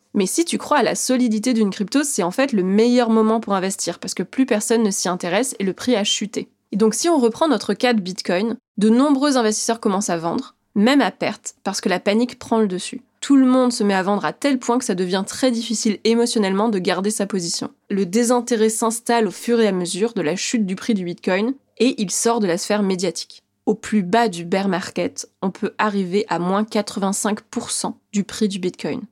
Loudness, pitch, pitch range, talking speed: -20 LUFS, 215 Hz, 195-235 Hz, 230 wpm